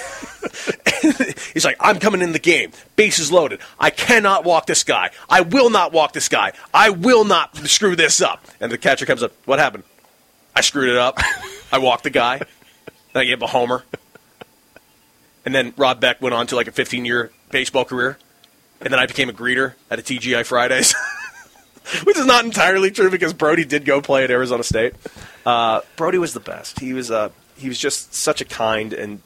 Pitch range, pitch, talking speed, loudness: 120-180 Hz, 135 Hz, 205 wpm, -17 LUFS